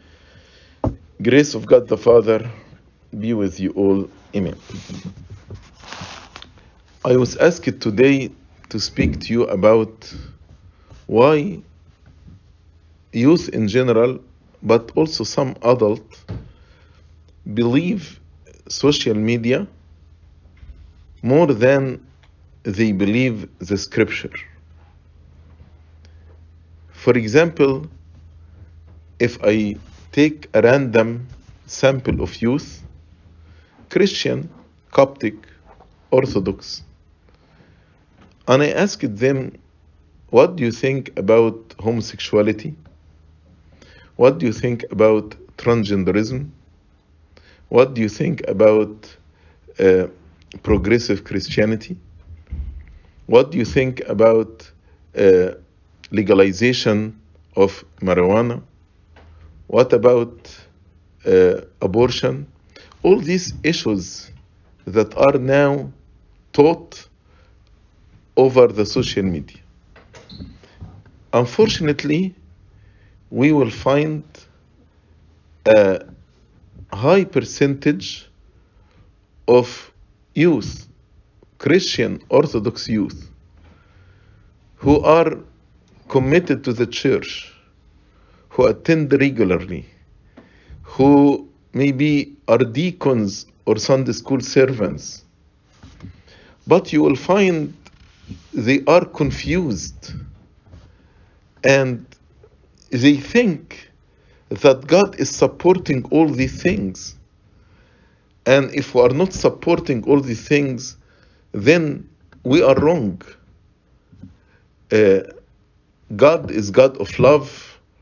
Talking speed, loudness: 80 wpm, -17 LUFS